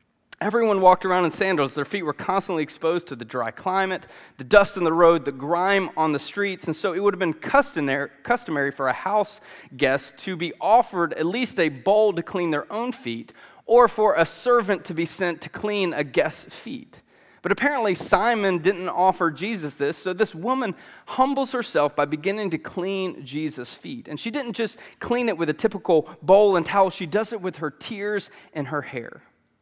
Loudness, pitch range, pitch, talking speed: -23 LUFS, 155-210 Hz, 185 Hz, 200 wpm